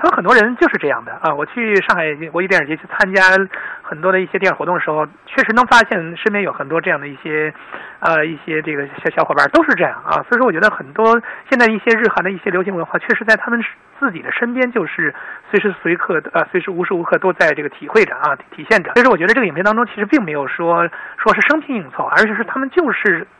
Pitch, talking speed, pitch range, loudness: 205 Hz, 390 characters per minute, 170-235 Hz, -15 LUFS